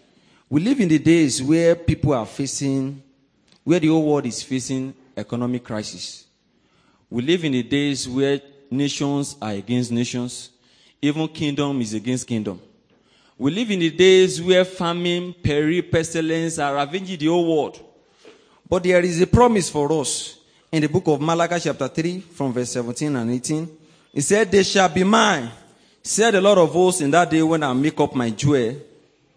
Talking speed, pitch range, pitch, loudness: 175 wpm, 130-175 Hz, 150 Hz, -20 LUFS